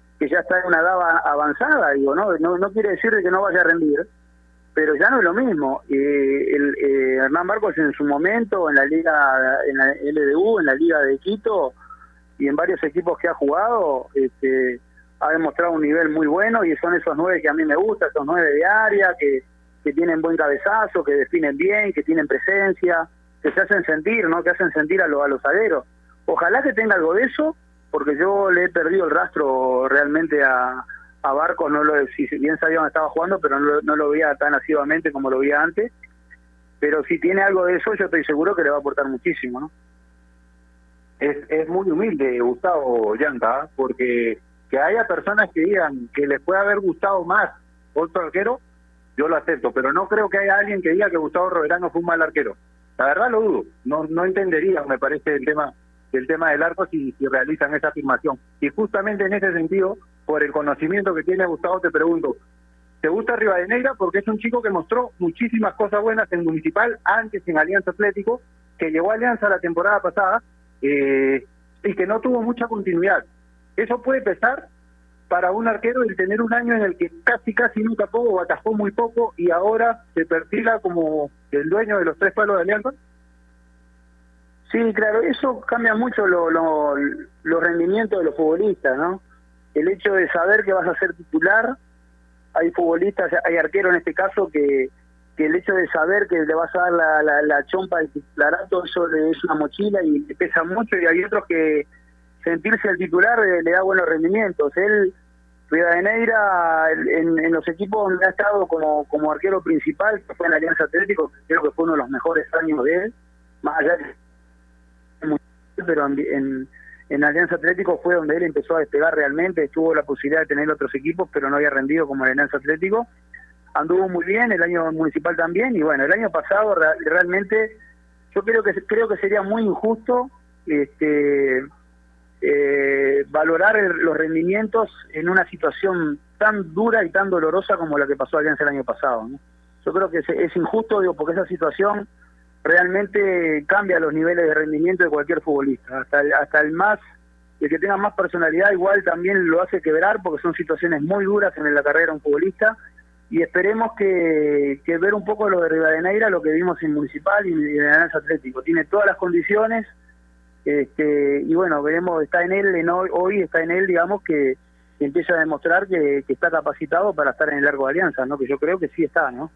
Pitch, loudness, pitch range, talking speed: 165 Hz, -20 LUFS, 145-195 Hz, 200 wpm